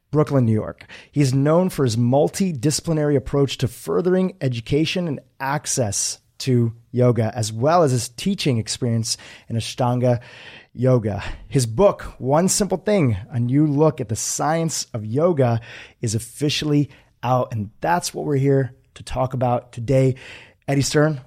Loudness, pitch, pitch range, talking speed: -21 LUFS, 130 Hz, 120-150 Hz, 145 wpm